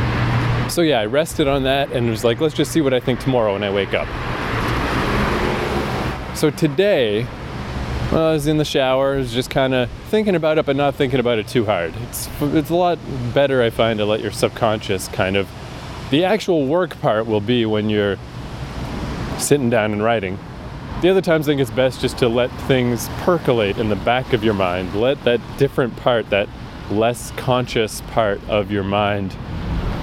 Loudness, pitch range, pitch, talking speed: -19 LUFS, 105-135 Hz, 120 Hz, 195 wpm